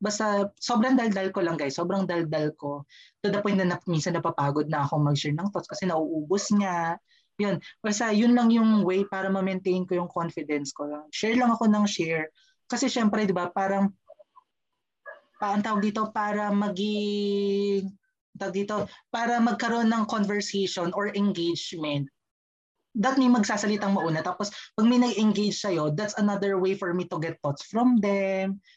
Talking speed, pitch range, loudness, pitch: 165 wpm, 170-215 Hz, -26 LUFS, 200 Hz